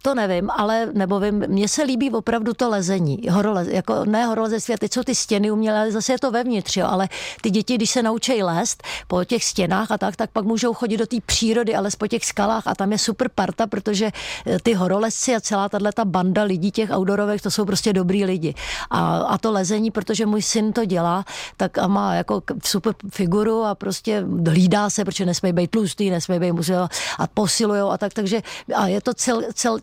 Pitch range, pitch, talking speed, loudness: 195-225 Hz, 210 Hz, 210 wpm, -21 LUFS